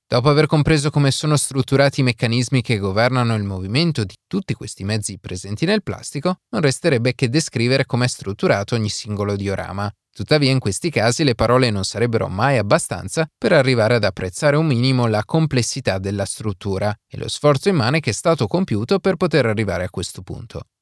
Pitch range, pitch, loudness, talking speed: 105-150 Hz, 125 Hz, -19 LUFS, 180 wpm